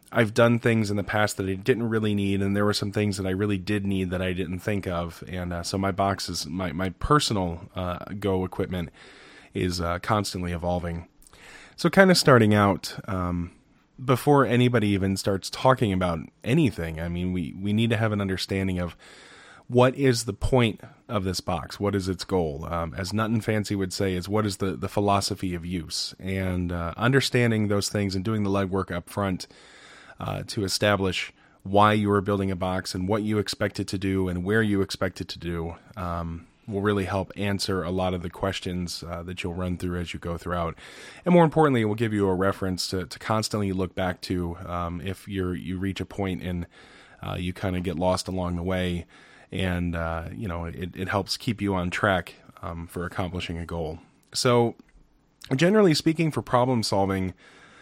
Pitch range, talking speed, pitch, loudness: 90-105 Hz, 205 wpm, 95 Hz, -26 LUFS